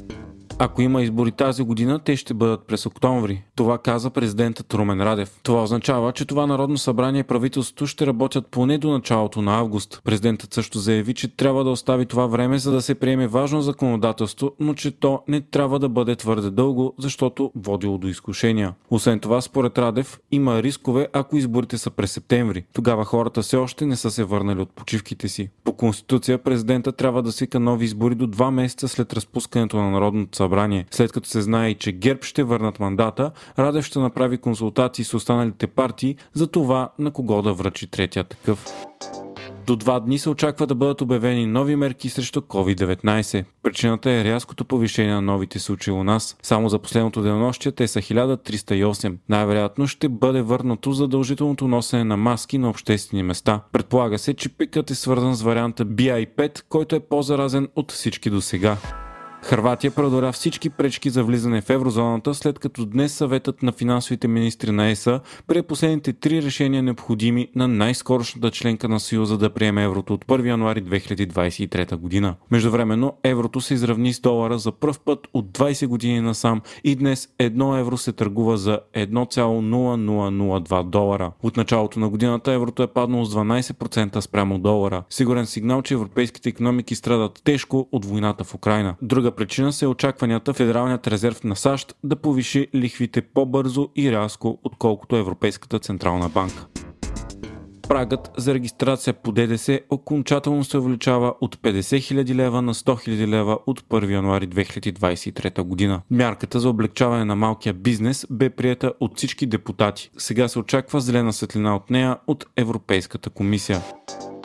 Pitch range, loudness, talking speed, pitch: 110-130 Hz, -22 LUFS, 165 wpm, 120 Hz